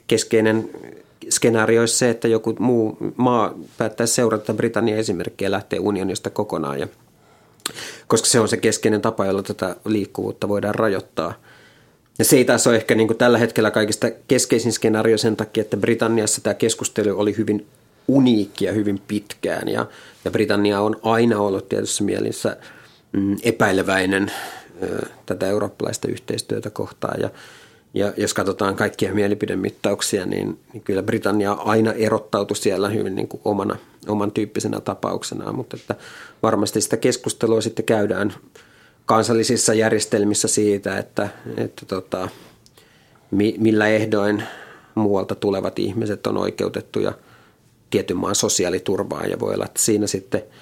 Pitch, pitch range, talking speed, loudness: 110 Hz, 105-115 Hz, 130 wpm, -20 LUFS